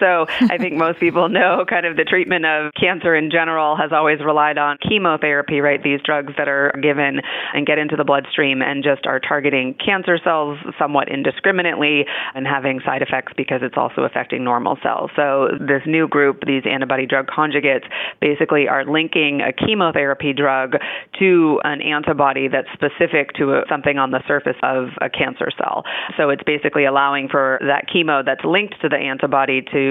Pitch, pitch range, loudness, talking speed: 145 Hz, 140-160 Hz, -17 LUFS, 180 wpm